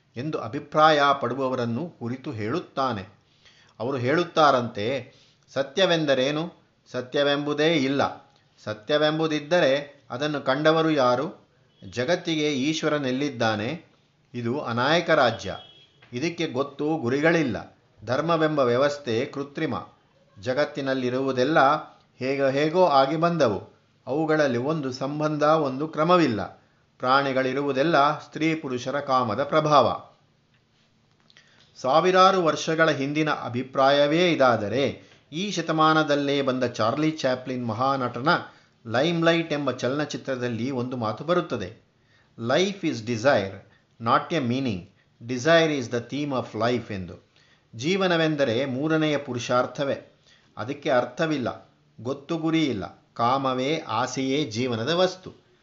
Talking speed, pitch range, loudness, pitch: 85 wpm, 125-155 Hz, -24 LUFS, 140 Hz